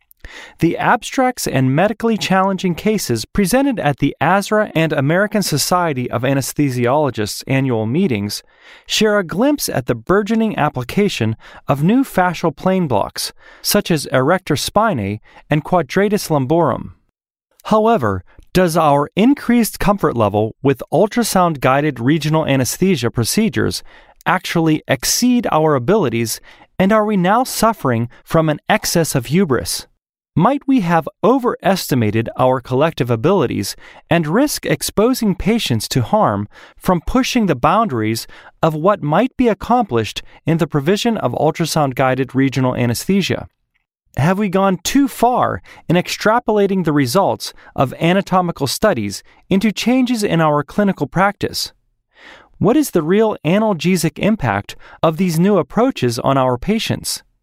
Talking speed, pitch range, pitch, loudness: 125 wpm, 135-210 Hz, 170 Hz, -16 LUFS